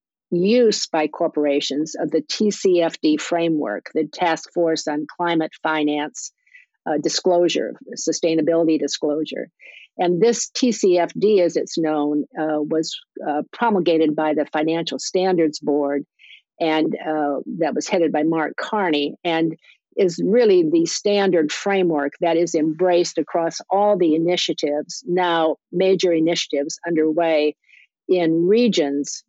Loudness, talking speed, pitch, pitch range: -20 LUFS, 120 wpm, 165 Hz, 155-180 Hz